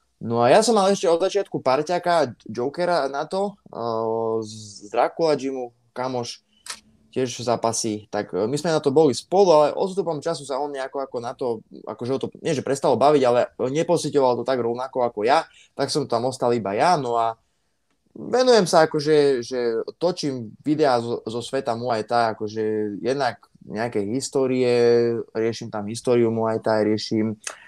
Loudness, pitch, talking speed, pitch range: -22 LUFS, 125 Hz, 170 wpm, 115-150 Hz